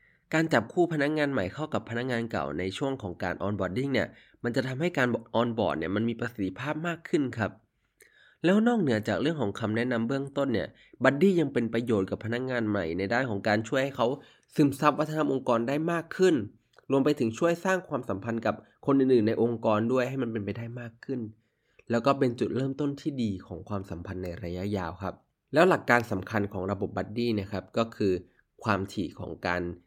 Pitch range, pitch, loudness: 100-140 Hz, 115 Hz, -29 LUFS